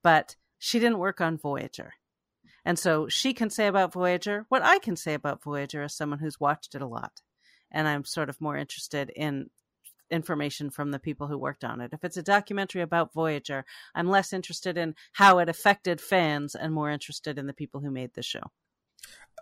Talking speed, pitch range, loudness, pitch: 200 wpm, 145-180 Hz, -28 LUFS, 155 Hz